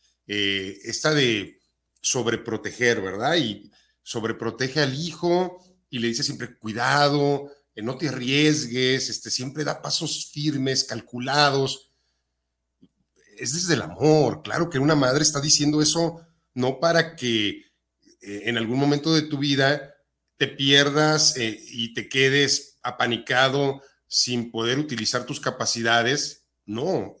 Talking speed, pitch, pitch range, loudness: 130 wpm, 135 Hz, 115-150 Hz, -22 LUFS